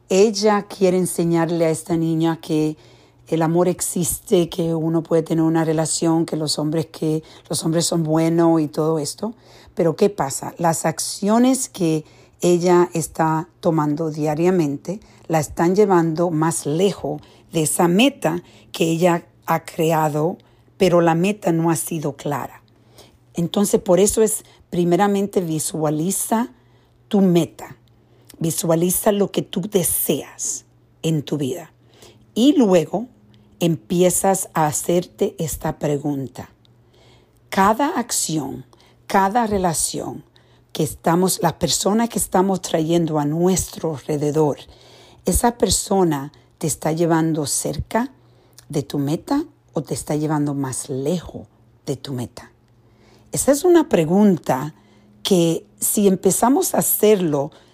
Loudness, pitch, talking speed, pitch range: -19 LUFS, 165 Hz, 125 wpm, 150-185 Hz